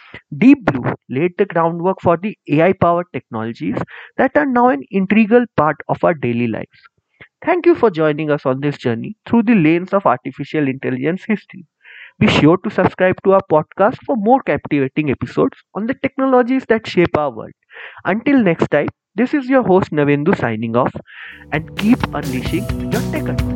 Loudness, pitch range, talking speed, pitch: -16 LUFS, 145-225 Hz, 175 wpm, 175 Hz